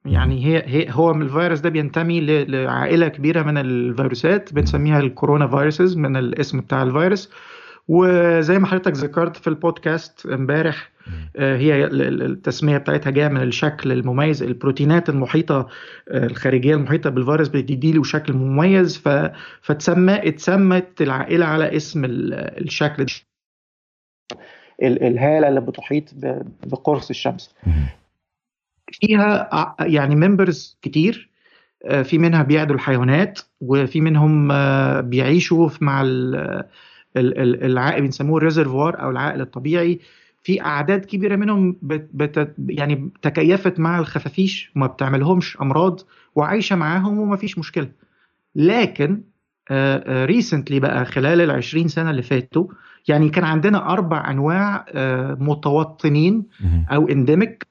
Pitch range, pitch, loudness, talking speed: 135-170 Hz, 155 Hz, -18 LUFS, 105 wpm